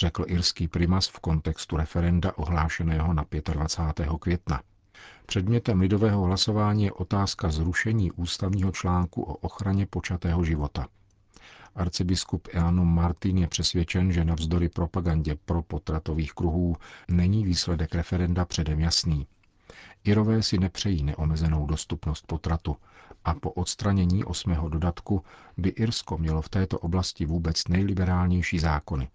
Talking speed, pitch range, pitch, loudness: 120 wpm, 80-95 Hz, 85 Hz, -27 LUFS